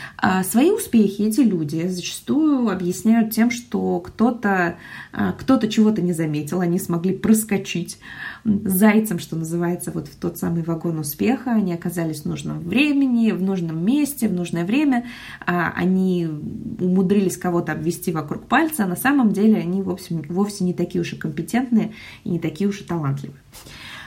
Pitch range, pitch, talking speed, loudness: 175-220 Hz, 185 Hz, 150 wpm, -21 LUFS